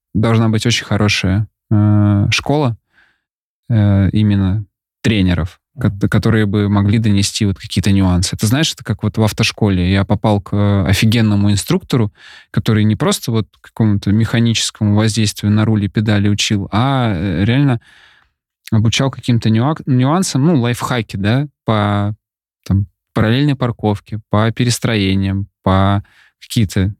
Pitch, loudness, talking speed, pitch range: 105 Hz, -15 LUFS, 125 wpm, 100-115 Hz